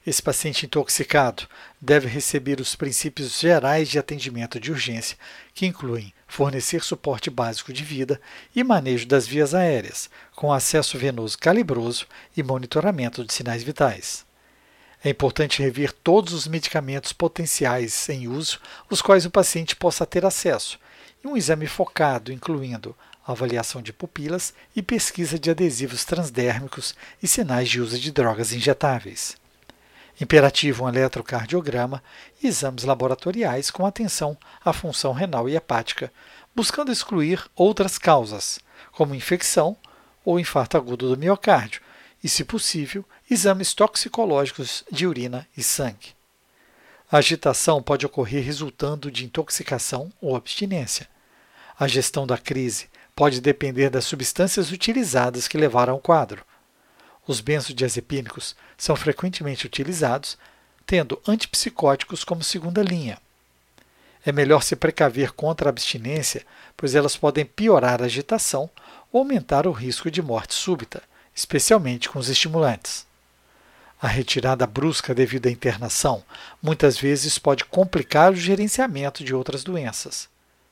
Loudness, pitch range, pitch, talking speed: -22 LUFS, 130-175 Hz, 145 Hz, 130 wpm